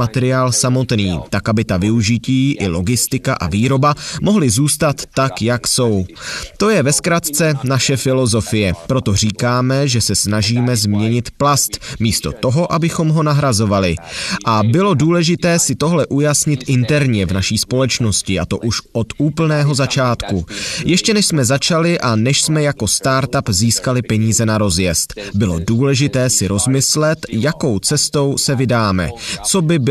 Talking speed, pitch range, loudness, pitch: 145 wpm, 110-145 Hz, -15 LUFS, 130 Hz